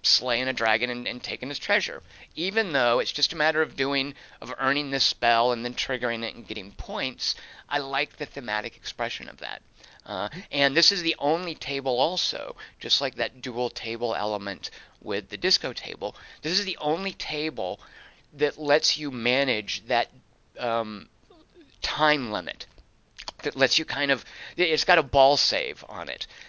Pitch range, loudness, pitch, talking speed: 120-150 Hz, -25 LUFS, 135 Hz, 175 wpm